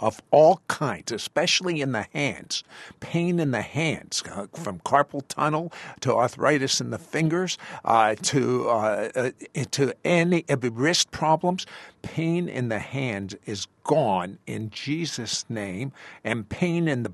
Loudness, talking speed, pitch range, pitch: -25 LUFS, 135 wpm, 115-165 Hz, 140 Hz